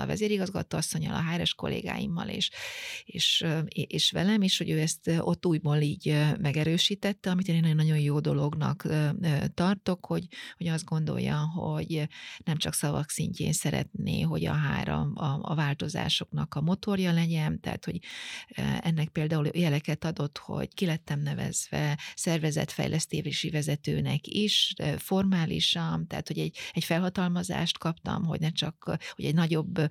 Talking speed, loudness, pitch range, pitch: 140 wpm, -29 LUFS, 150-180 Hz, 160 Hz